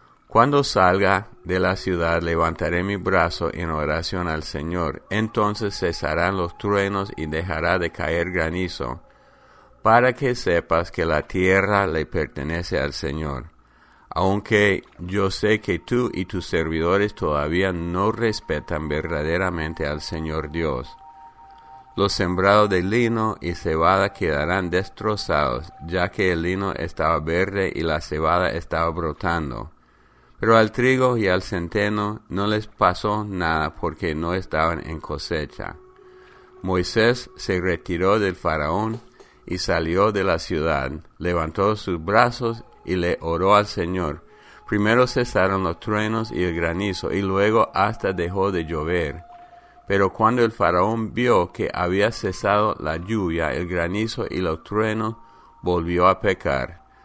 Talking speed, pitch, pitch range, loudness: 135 wpm, 95 Hz, 85-105 Hz, -22 LUFS